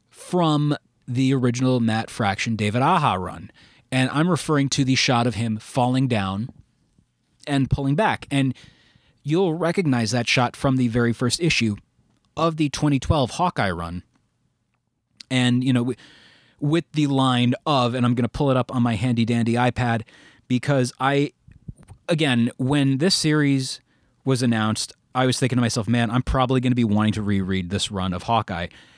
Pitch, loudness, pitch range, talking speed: 125 Hz, -22 LUFS, 115-140 Hz, 170 wpm